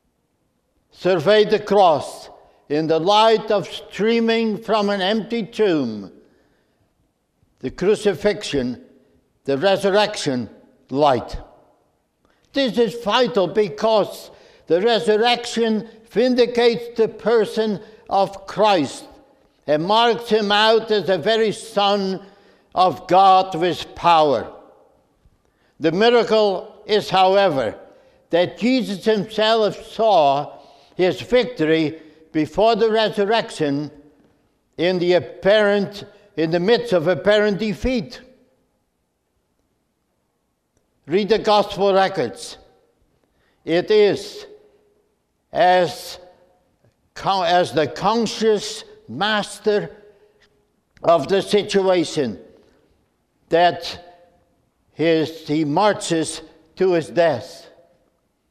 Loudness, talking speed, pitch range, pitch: -19 LUFS, 85 wpm, 175-220 Hz, 205 Hz